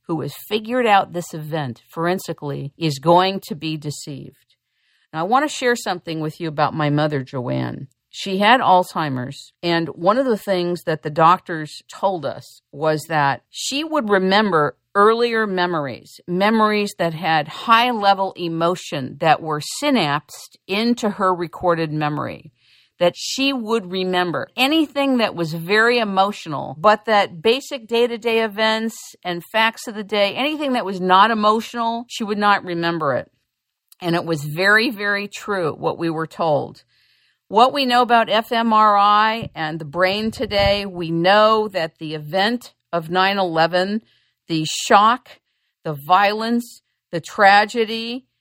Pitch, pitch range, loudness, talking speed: 195 Hz, 165-225 Hz, -19 LUFS, 150 wpm